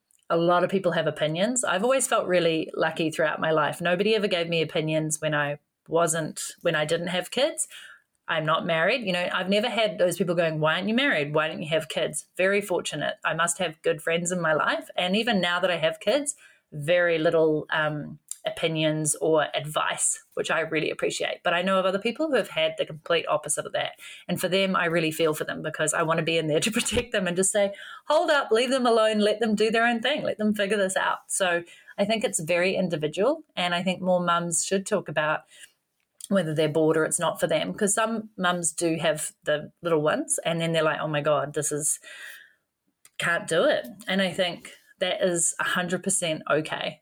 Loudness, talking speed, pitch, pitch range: -25 LUFS, 220 wpm, 180 Hz, 160-215 Hz